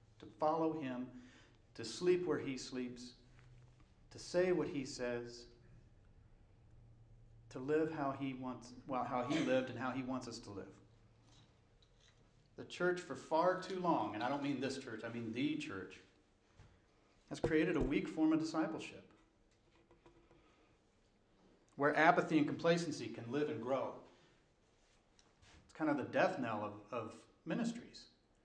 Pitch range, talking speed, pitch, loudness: 115-155 Hz, 145 wpm, 125 Hz, -39 LUFS